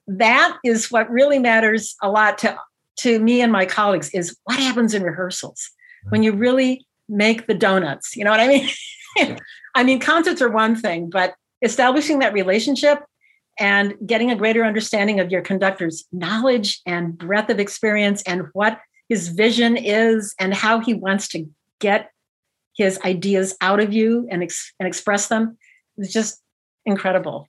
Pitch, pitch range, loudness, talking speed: 215 Hz, 195-235 Hz, -18 LUFS, 165 wpm